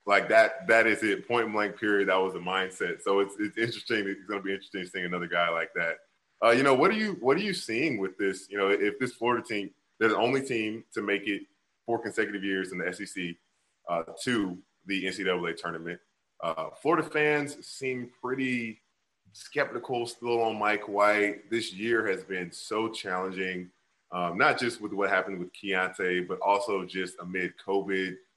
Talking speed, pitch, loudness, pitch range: 190 wpm, 100 Hz, -29 LUFS, 95-115 Hz